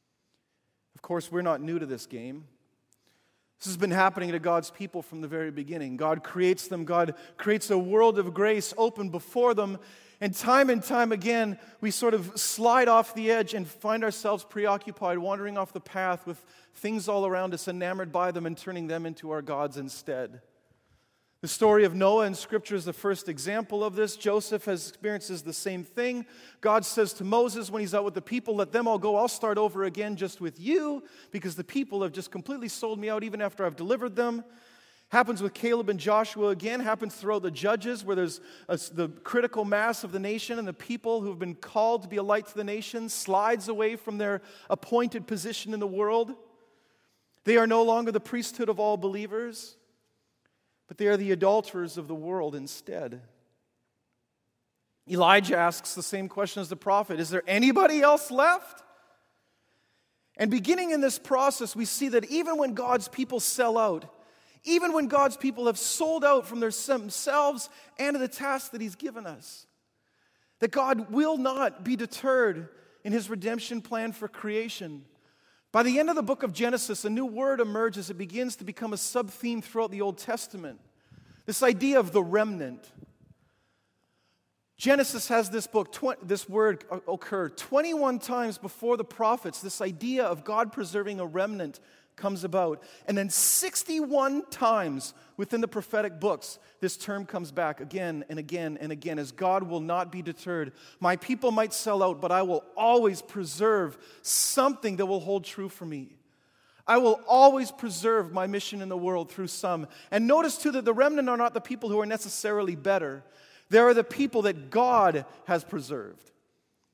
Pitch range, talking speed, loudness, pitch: 185-235 Hz, 185 wpm, -28 LUFS, 210 Hz